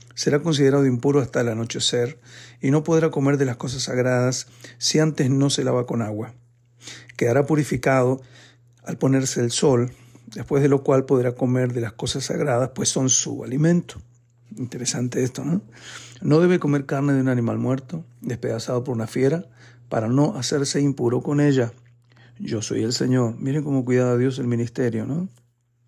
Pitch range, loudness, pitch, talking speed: 120-140 Hz, -22 LUFS, 125 Hz, 170 wpm